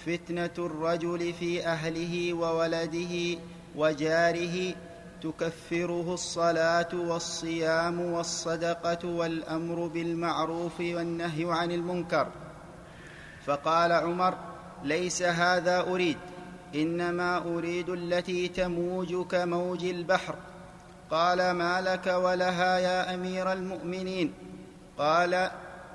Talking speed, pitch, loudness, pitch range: 80 wpm, 175 Hz, -29 LUFS, 170-180 Hz